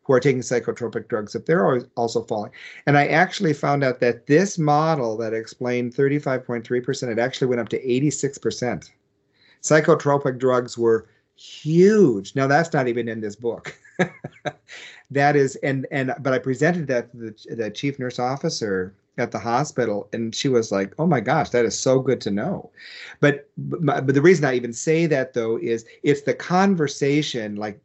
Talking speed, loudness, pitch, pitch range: 175 wpm, -21 LUFS, 130 Hz, 120-145 Hz